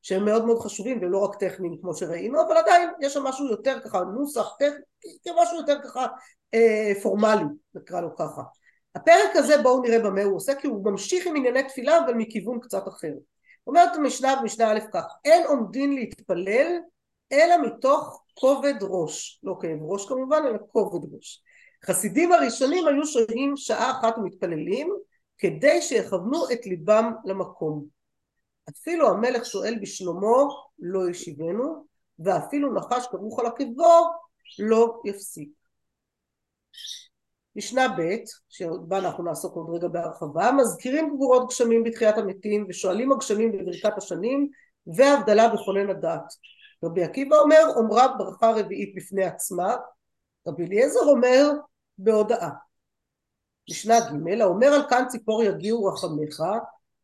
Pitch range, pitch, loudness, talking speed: 195-285 Hz, 230 Hz, -23 LUFS, 135 wpm